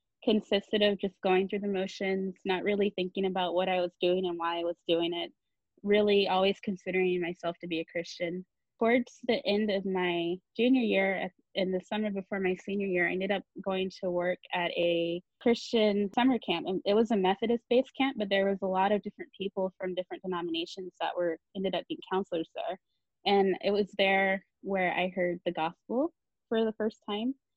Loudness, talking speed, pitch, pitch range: -30 LUFS, 200 wpm, 190 Hz, 180-205 Hz